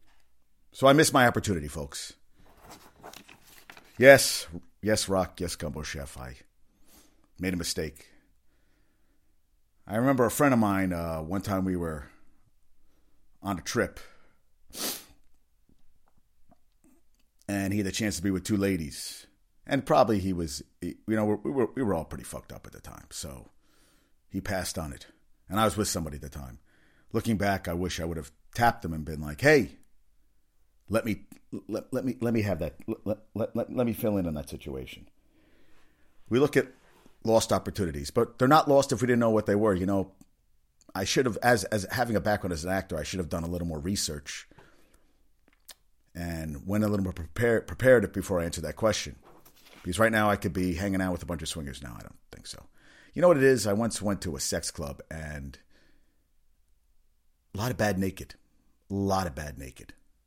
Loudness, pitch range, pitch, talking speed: -27 LUFS, 75-105 Hz, 95 Hz, 190 wpm